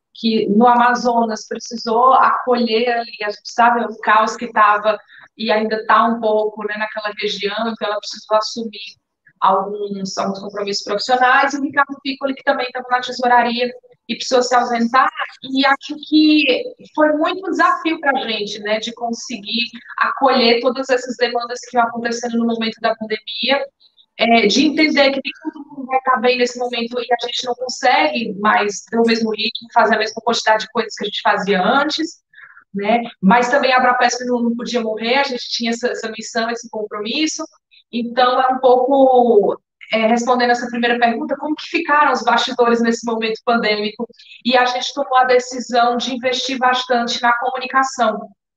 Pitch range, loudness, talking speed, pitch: 225-255 Hz, -17 LUFS, 175 wpm, 240 Hz